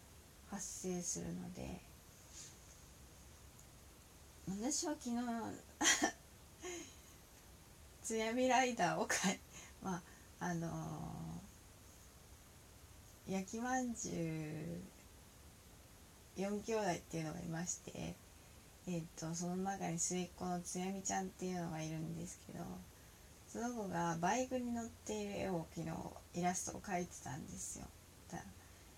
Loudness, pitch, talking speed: -42 LUFS, 160 Hz, 220 characters per minute